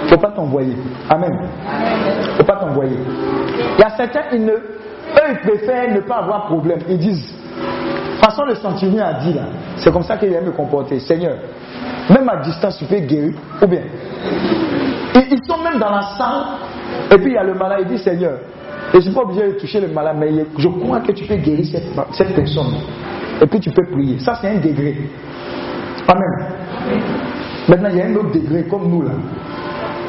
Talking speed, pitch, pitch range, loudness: 210 wpm, 180 Hz, 155-205 Hz, -16 LUFS